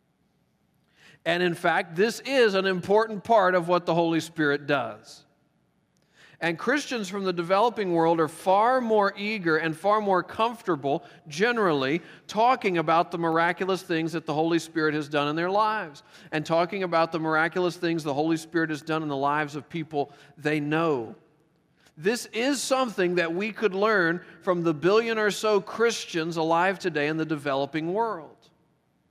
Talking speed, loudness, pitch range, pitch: 165 wpm, -25 LUFS, 160-205 Hz, 170 Hz